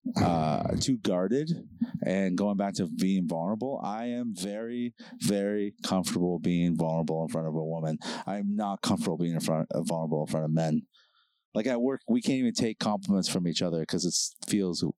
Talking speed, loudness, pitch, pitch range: 195 wpm, -30 LUFS, 95 Hz, 80-120 Hz